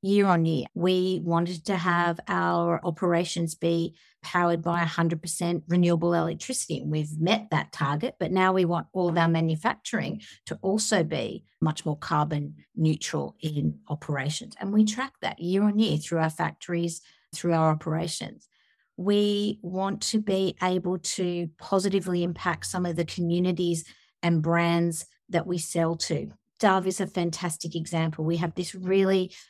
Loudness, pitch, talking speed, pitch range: -27 LUFS, 170 Hz, 155 wpm, 165-185 Hz